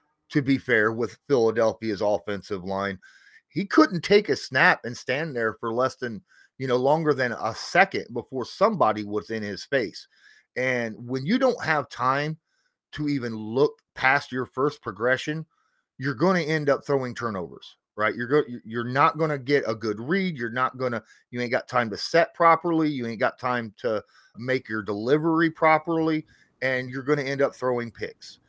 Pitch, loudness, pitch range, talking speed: 130 Hz, -25 LUFS, 115-155 Hz, 185 wpm